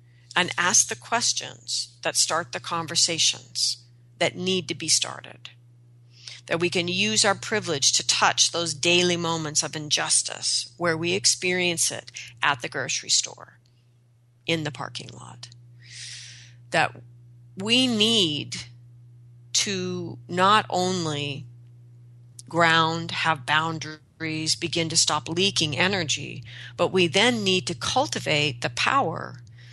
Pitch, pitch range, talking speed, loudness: 150 Hz, 120-170 Hz, 120 wpm, -23 LUFS